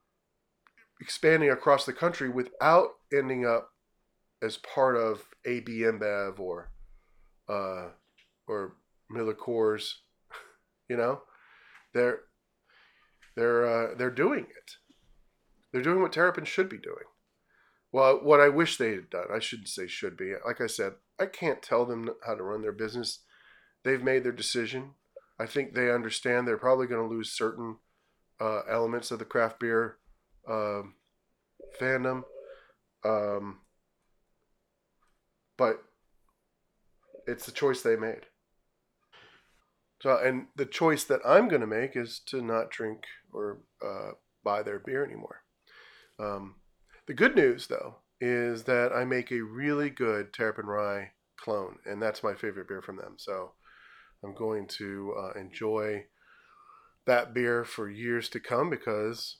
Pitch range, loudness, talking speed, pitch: 110-135 Hz, -29 LUFS, 140 wpm, 120 Hz